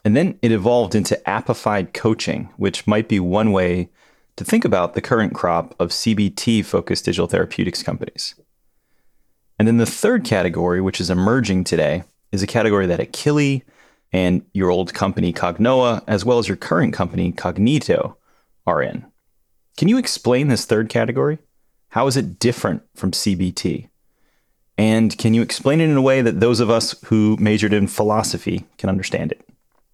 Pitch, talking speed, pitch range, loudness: 110 Hz, 165 wpm, 95-120 Hz, -19 LUFS